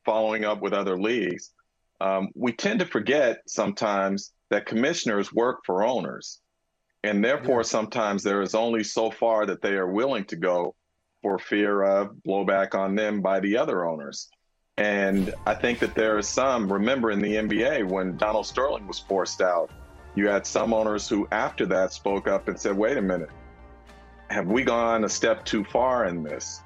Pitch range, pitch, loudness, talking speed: 95-105 Hz, 100 Hz, -25 LUFS, 180 wpm